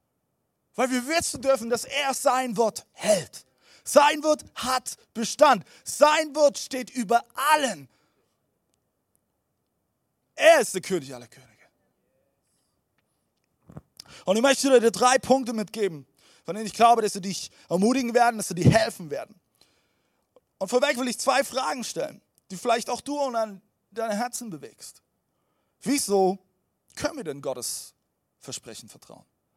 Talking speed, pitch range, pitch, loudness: 135 wpm, 200-270 Hz, 240 Hz, -24 LUFS